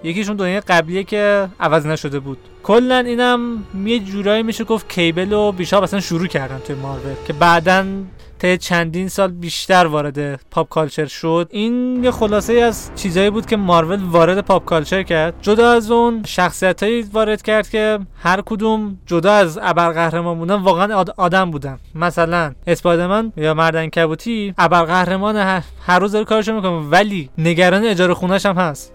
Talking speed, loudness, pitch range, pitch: 160 wpm, -16 LUFS, 170-210 Hz, 185 Hz